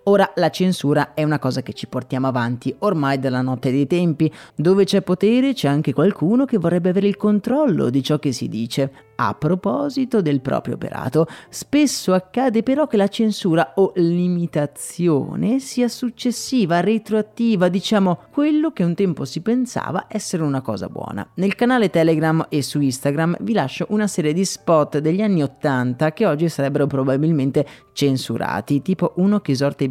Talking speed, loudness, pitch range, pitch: 165 wpm, -19 LUFS, 140-210 Hz, 170 Hz